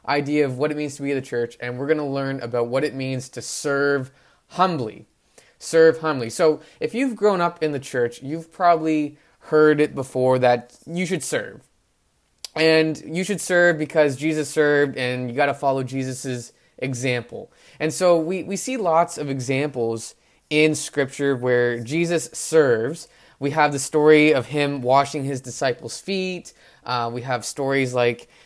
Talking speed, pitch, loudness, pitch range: 175 wpm, 145 Hz, -21 LUFS, 130-160 Hz